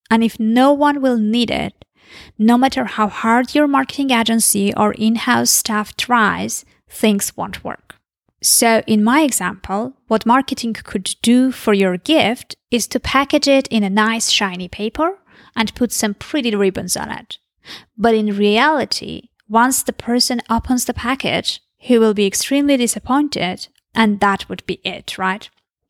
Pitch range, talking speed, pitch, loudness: 210-260 Hz, 160 wpm, 230 Hz, -16 LUFS